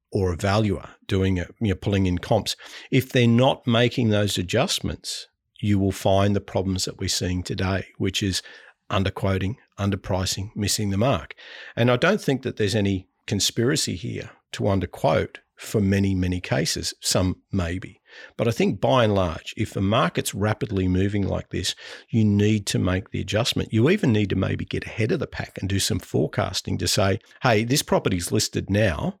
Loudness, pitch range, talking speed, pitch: -23 LUFS, 95-115 Hz, 185 wpm, 100 Hz